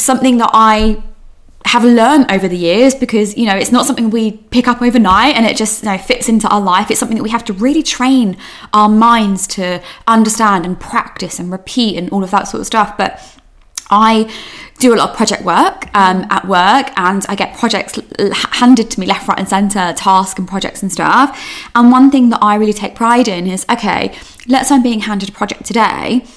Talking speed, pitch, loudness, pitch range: 220 wpm, 220 Hz, -11 LUFS, 195-245 Hz